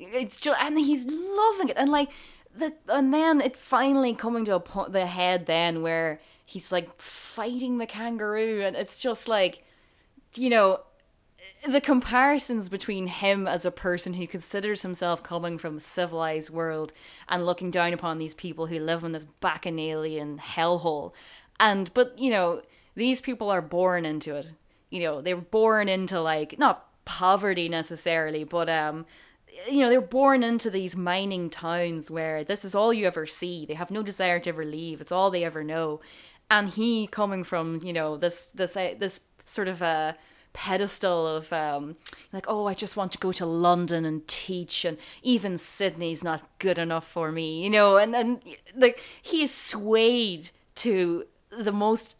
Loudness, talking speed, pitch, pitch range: -26 LUFS, 175 wpm, 185 Hz, 165-225 Hz